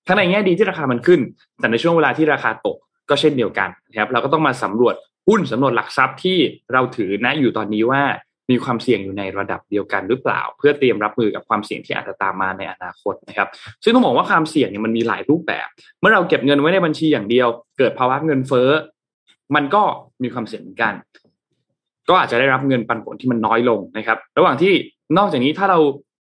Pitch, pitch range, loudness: 130 Hz, 115-155 Hz, -18 LUFS